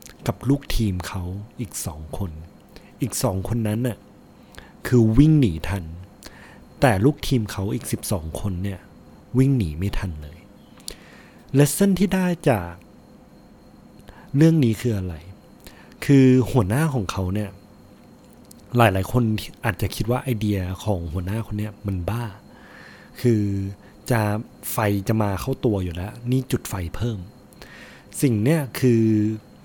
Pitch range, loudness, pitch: 95-125 Hz, -22 LUFS, 105 Hz